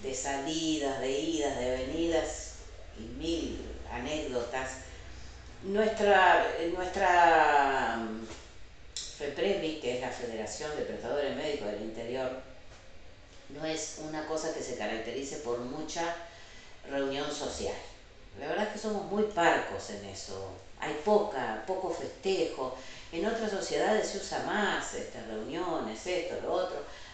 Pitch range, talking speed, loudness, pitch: 110-165 Hz, 125 wpm, -32 LUFS, 140 Hz